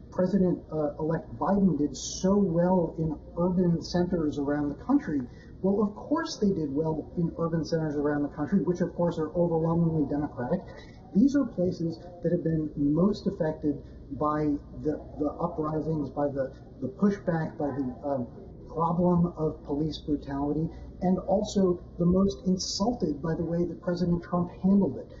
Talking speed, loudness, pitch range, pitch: 160 wpm, -28 LUFS, 150-180 Hz, 165 Hz